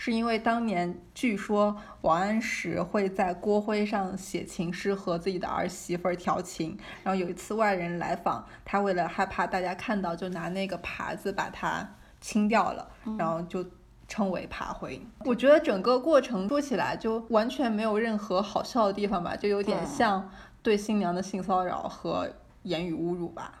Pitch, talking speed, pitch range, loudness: 195 Hz, 265 characters per minute, 180-220 Hz, -29 LUFS